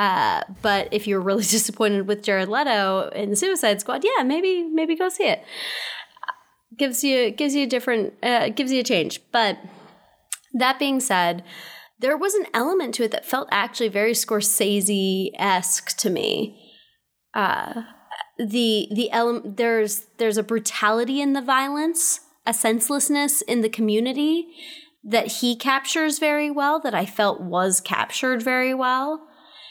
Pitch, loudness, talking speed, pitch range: 245 Hz, -22 LUFS, 150 wpm, 215-295 Hz